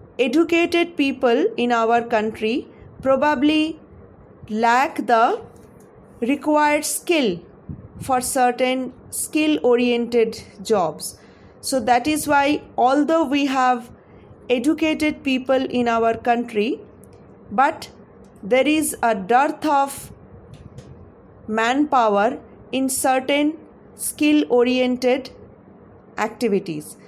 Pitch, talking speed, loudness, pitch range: 255 Hz, 85 wpm, -20 LUFS, 235-295 Hz